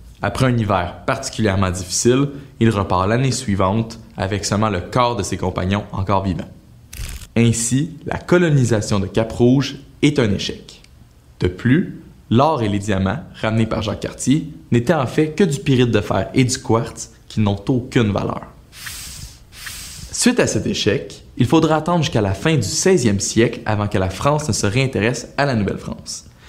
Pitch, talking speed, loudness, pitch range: 115 Hz, 170 wpm, -18 LUFS, 100-135 Hz